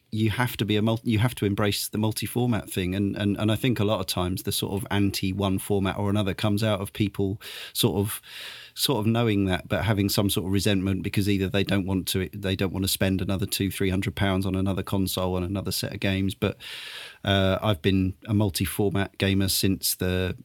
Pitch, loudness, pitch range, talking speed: 100 Hz, -26 LUFS, 95-105 Hz, 230 wpm